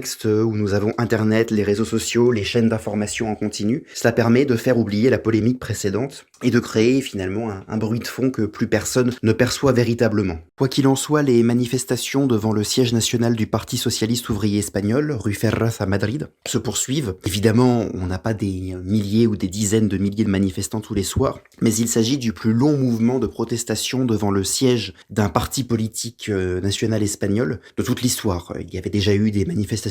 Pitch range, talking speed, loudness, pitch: 105-120 Hz, 200 wpm, -20 LUFS, 110 Hz